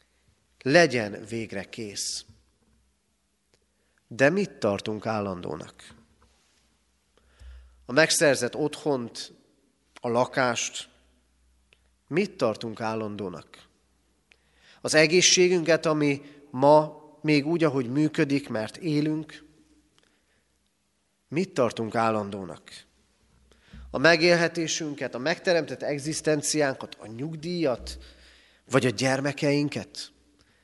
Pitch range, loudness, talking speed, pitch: 100-150 Hz, -25 LUFS, 75 wpm, 125 Hz